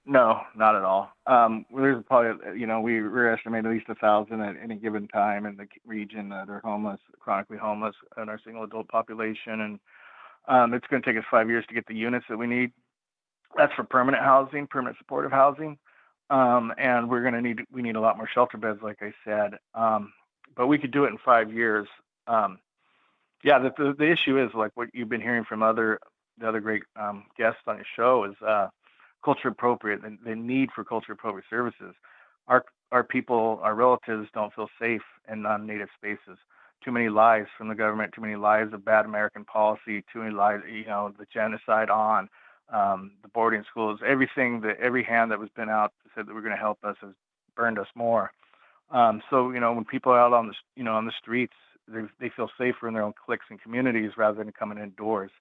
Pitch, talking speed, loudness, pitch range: 110 Hz, 210 wpm, -26 LUFS, 105-120 Hz